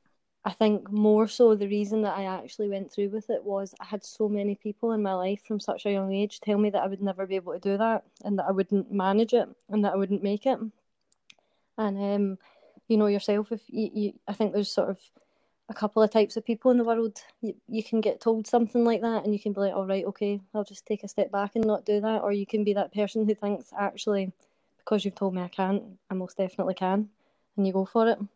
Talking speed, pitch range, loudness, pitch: 260 wpm, 195-220 Hz, -28 LUFS, 205 Hz